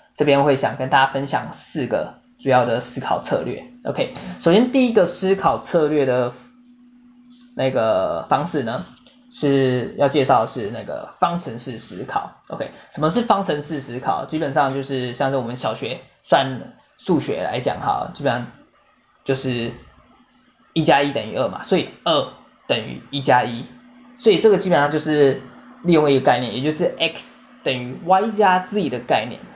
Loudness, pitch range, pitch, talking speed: -20 LUFS, 130-210 Hz, 145 Hz, 245 characters per minute